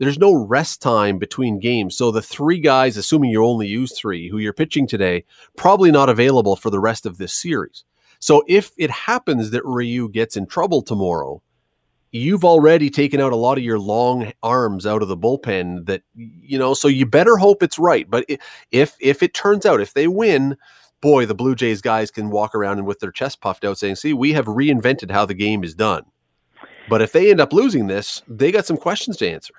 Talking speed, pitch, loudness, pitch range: 215 wpm, 125 Hz, -17 LUFS, 105-145 Hz